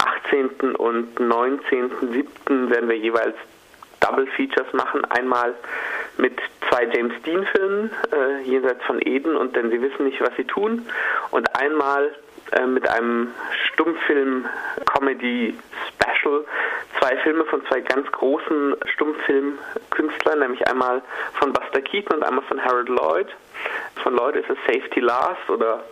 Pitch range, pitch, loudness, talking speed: 120-155 Hz, 135 Hz, -22 LUFS, 130 wpm